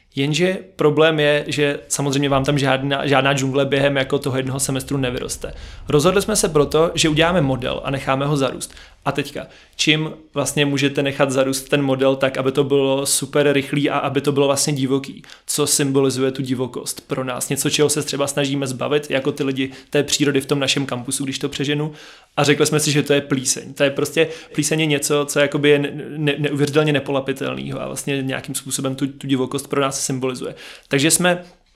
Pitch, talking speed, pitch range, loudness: 140 Hz, 195 wpm, 135-150 Hz, -19 LUFS